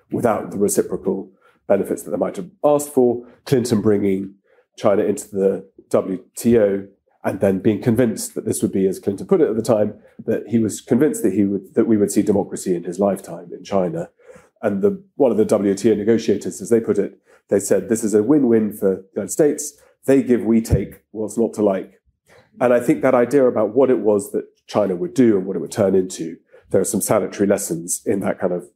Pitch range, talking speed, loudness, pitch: 100-135 Hz, 220 wpm, -19 LUFS, 115 Hz